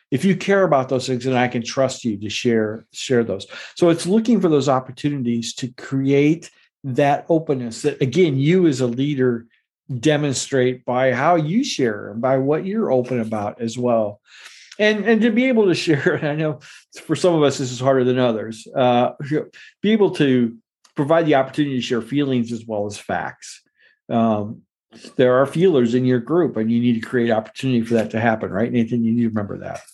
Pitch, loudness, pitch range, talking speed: 130 Hz, -19 LUFS, 120-150 Hz, 200 wpm